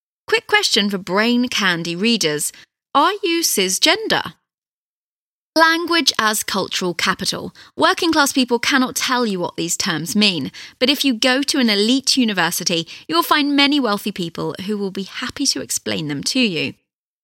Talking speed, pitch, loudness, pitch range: 155 wpm, 240 Hz, -17 LUFS, 195-285 Hz